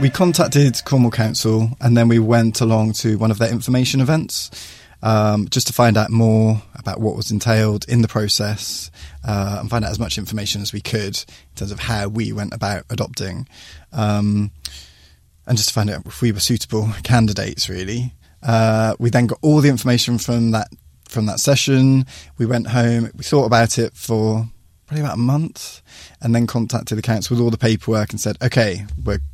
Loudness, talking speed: -18 LUFS, 195 wpm